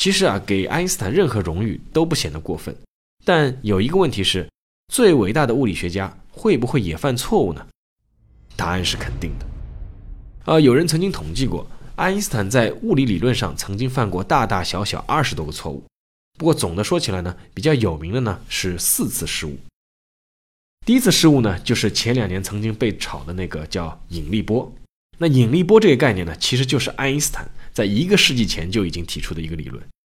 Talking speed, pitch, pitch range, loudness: 305 characters per minute, 100 Hz, 85-135 Hz, -19 LUFS